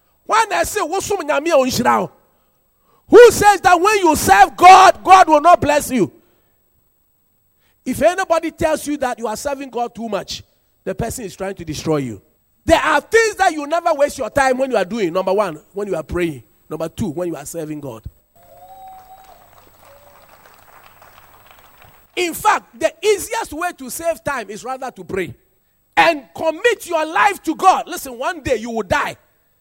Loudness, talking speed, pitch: -15 LUFS, 170 wpm, 290 Hz